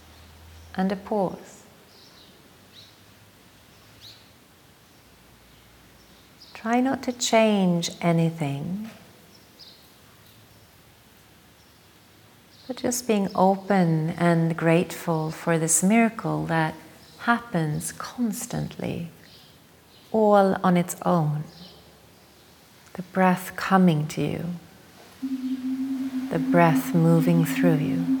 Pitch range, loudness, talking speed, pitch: 135-205 Hz, -24 LUFS, 70 wpm, 170 Hz